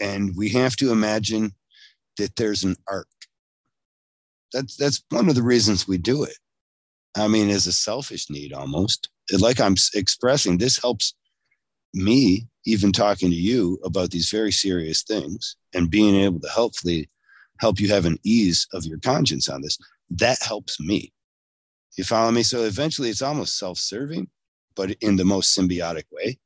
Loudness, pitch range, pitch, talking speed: -21 LUFS, 90-110 Hz, 100 Hz, 165 wpm